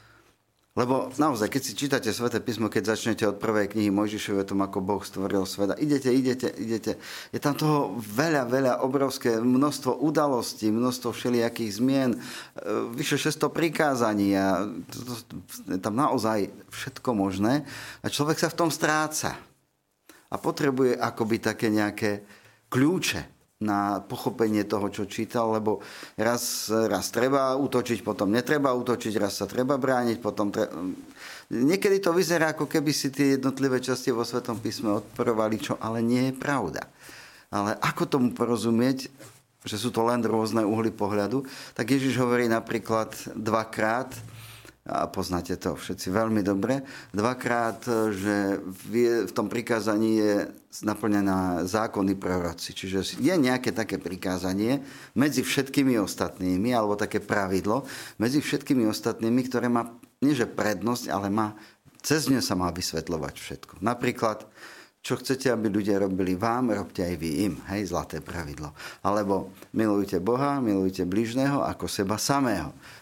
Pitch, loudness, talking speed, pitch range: 115 Hz, -27 LUFS, 140 wpm, 105-130 Hz